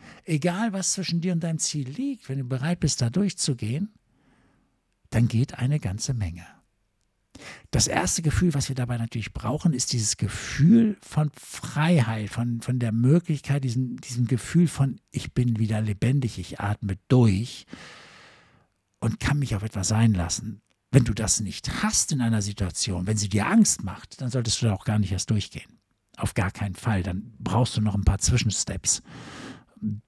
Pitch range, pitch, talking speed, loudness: 105-140 Hz, 120 Hz, 175 wpm, -25 LUFS